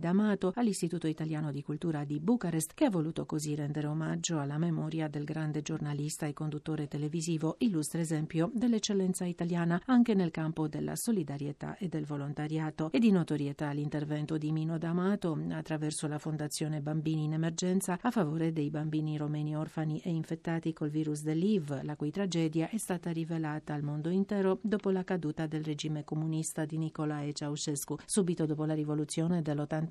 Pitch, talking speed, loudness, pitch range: 155 Hz, 160 wpm, -33 LUFS, 150-170 Hz